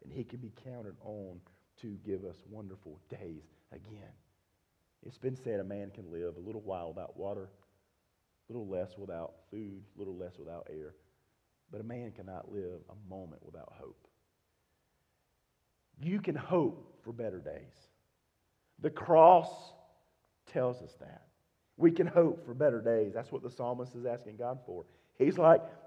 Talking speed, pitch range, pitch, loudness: 160 wpm, 95-125 Hz, 105 Hz, -32 LUFS